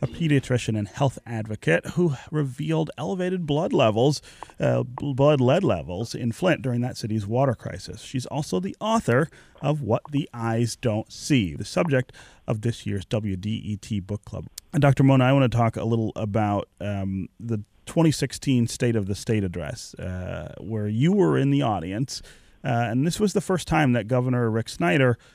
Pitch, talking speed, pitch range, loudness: 120 Hz, 180 wpm, 110-145 Hz, -24 LUFS